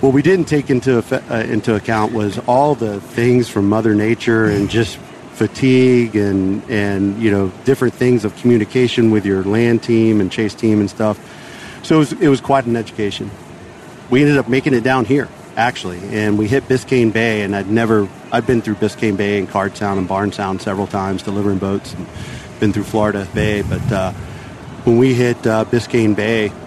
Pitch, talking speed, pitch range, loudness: 110 Hz, 195 wpm, 100-125 Hz, -16 LUFS